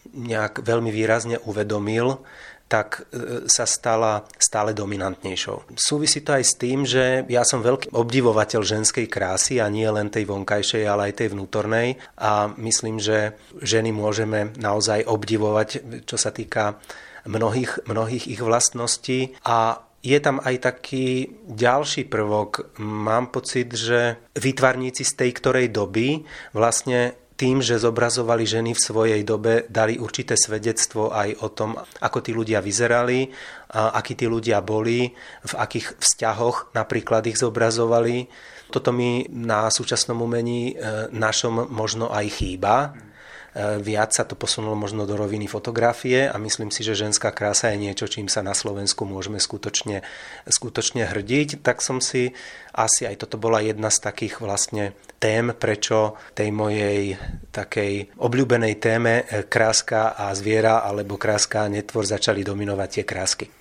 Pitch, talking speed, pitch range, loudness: 115 Hz, 140 wpm, 105-120 Hz, -22 LUFS